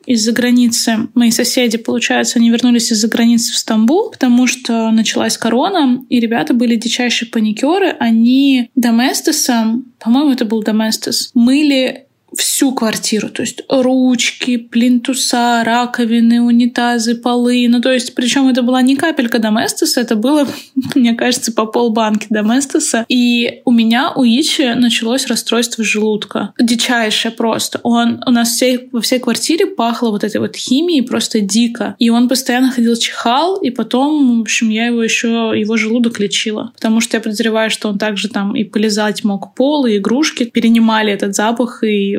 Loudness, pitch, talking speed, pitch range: -13 LUFS, 240 Hz, 155 wpm, 225-255 Hz